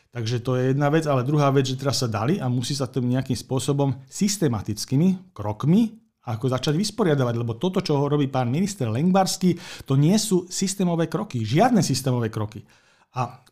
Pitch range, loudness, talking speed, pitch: 125-175 Hz, -23 LUFS, 175 wpm, 140 Hz